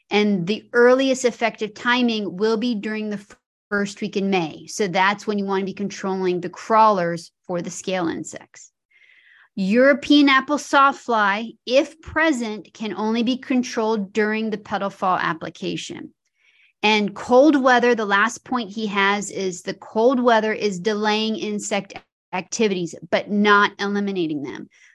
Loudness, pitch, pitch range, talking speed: -20 LUFS, 215 Hz, 195-245 Hz, 150 wpm